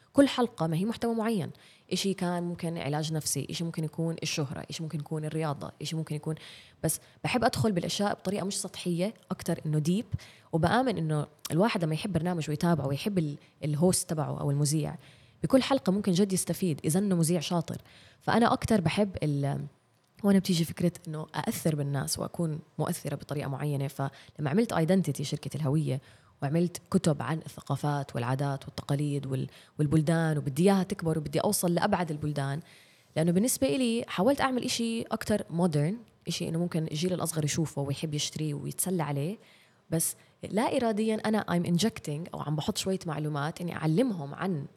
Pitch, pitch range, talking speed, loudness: 165 Hz, 150-190 Hz, 160 wpm, -30 LUFS